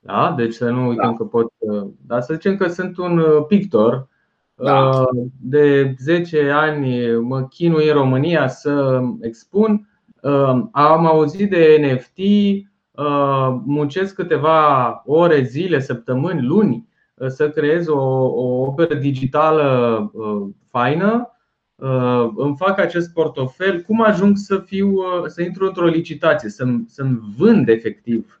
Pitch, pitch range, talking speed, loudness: 150 Hz, 130-175 Hz, 120 wpm, -17 LUFS